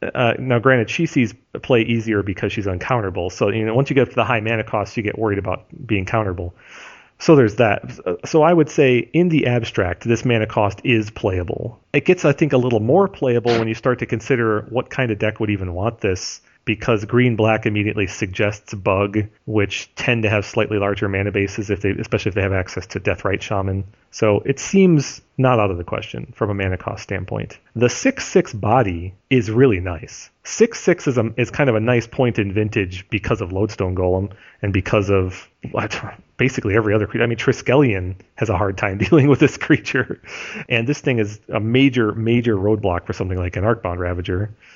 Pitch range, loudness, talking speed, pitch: 100-125 Hz, -19 LUFS, 210 wpm, 110 Hz